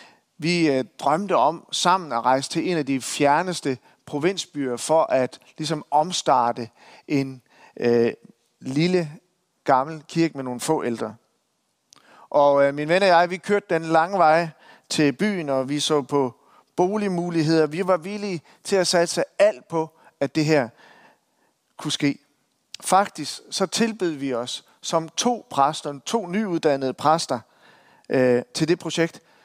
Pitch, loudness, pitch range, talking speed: 155 Hz, -22 LUFS, 135-175 Hz, 145 wpm